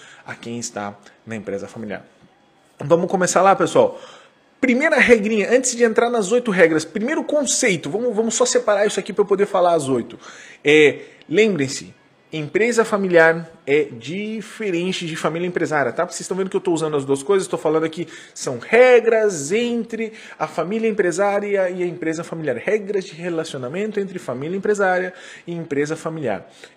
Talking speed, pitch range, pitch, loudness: 165 wpm, 160-220 Hz, 190 Hz, -19 LUFS